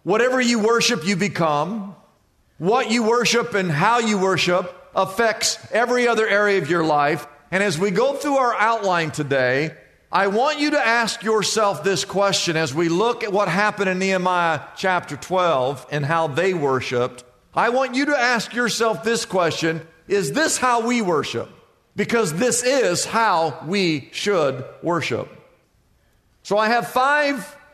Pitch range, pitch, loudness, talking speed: 165-235 Hz, 200 Hz, -20 LUFS, 160 wpm